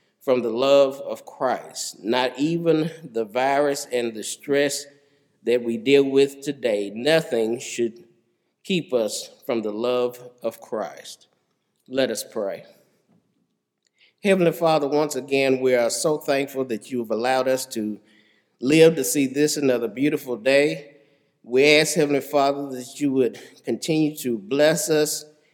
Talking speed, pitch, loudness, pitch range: 145 wpm, 140 Hz, -22 LUFS, 125-150 Hz